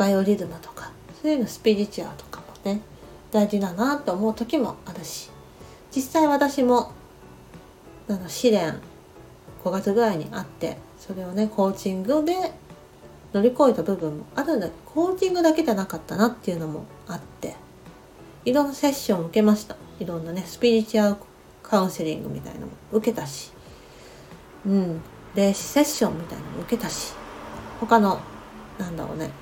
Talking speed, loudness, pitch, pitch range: 355 characters per minute, -24 LUFS, 210 Hz, 185-245 Hz